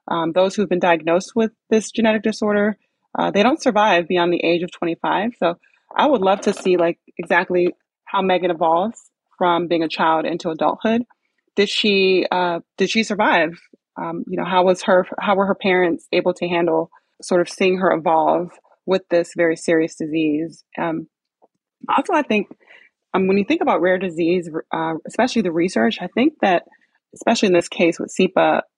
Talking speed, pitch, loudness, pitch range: 185 wpm, 180 Hz, -19 LUFS, 170-210 Hz